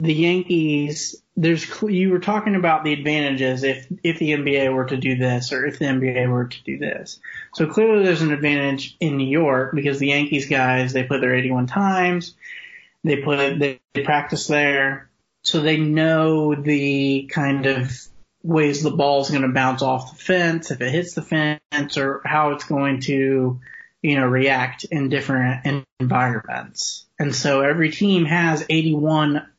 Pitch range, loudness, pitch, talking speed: 135-160 Hz, -20 LUFS, 145 Hz, 170 wpm